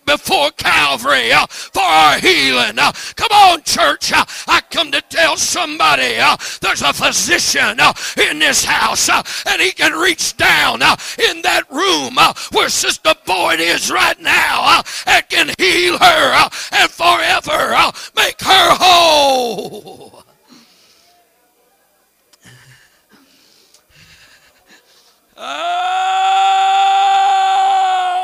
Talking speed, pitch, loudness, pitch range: 115 wpm, 355 Hz, -12 LUFS, 320-385 Hz